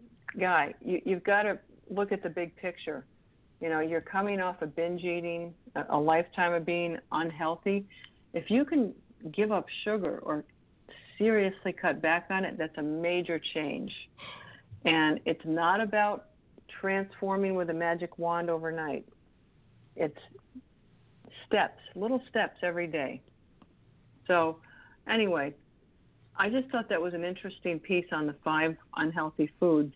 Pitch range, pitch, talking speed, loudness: 160-195 Hz, 175 Hz, 140 wpm, -31 LUFS